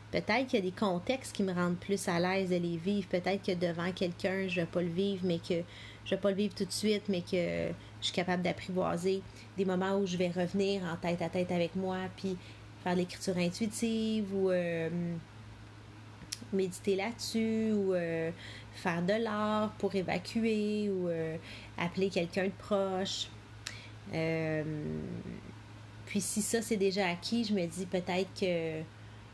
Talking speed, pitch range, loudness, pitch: 175 wpm, 165-195 Hz, -34 LUFS, 180 Hz